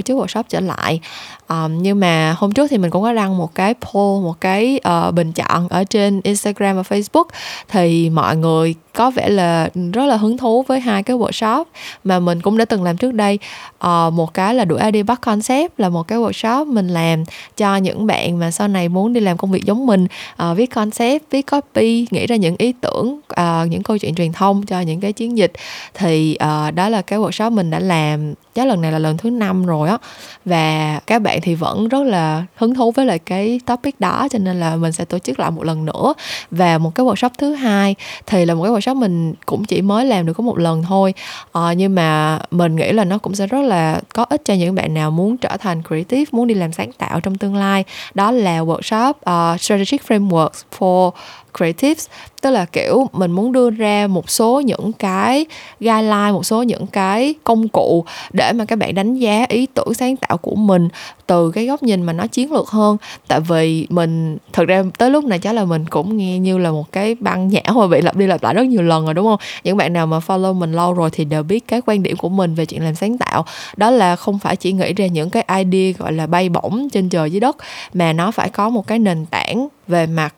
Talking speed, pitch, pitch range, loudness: 235 wpm, 195 Hz, 170-230 Hz, -16 LUFS